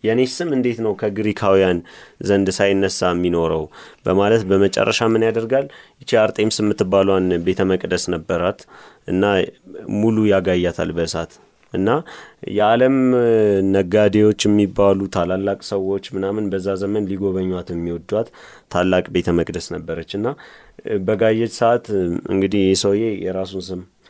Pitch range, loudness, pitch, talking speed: 90-105 Hz, -19 LUFS, 100 Hz, 110 wpm